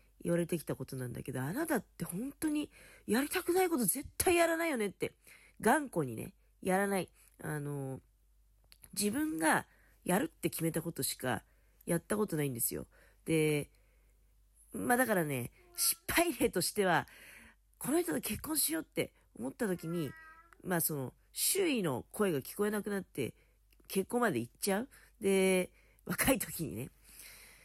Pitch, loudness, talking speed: 195 Hz, -34 LUFS, 295 characters per minute